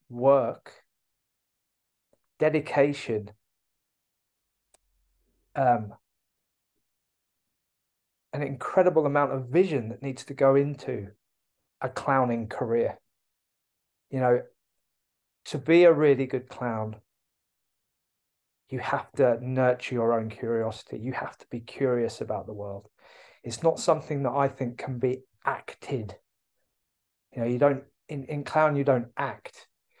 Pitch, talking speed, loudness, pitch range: 130 Hz, 115 wpm, -27 LUFS, 115-140 Hz